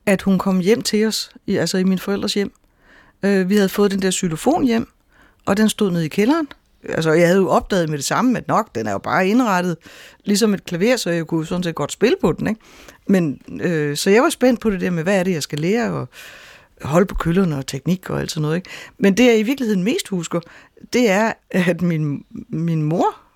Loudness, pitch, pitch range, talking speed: -19 LUFS, 190 Hz, 170-220 Hz, 240 wpm